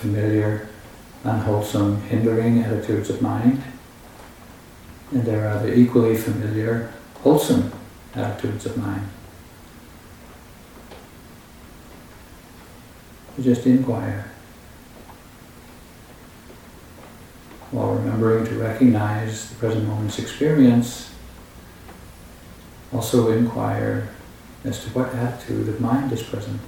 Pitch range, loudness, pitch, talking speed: 105-120 Hz, -21 LUFS, 115 Hz, 85 wpm